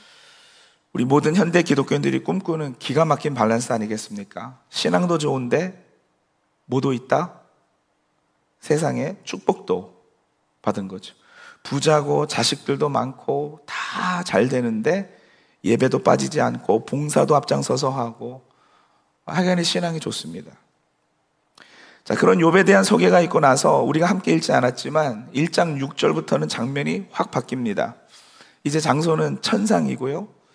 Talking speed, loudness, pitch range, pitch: 270 characters per minute, -21 LUFS, 115-175 Hz, 145 Hz